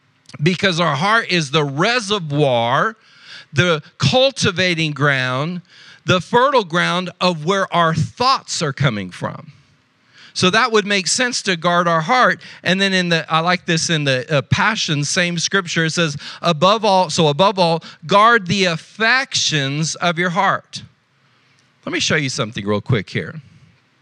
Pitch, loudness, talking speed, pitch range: 170 Hz, -17 LUFS, 155 wpm, 150-195 Hz